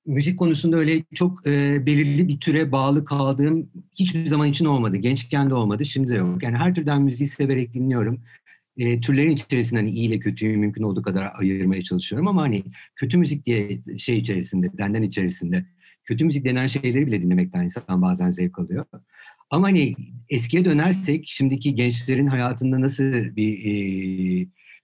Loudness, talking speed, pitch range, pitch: -22 LUFS, 160 wpm, 105-150 Hz, 135 Hz